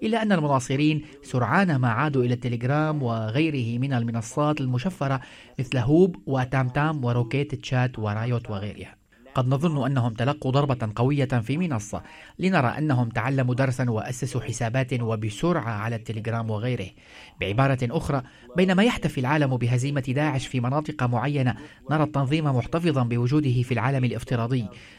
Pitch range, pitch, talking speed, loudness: 120-145 Hz, 130 Hz, 130 wpm, -25 LUFS